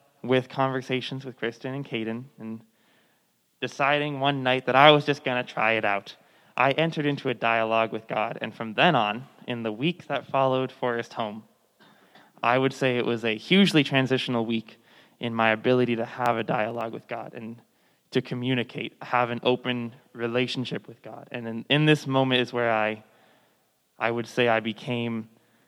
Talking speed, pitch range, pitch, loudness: 180 wpm, 115-135 Hz, 125 Hz, -25 LUFS